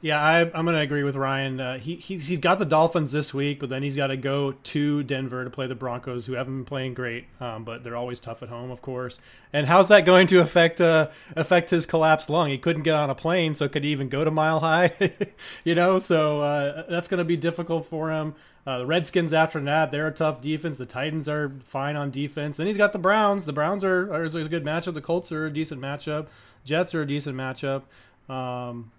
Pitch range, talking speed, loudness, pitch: 135-170 Hz, 245 wpm, -24 LUFS, 155 Hz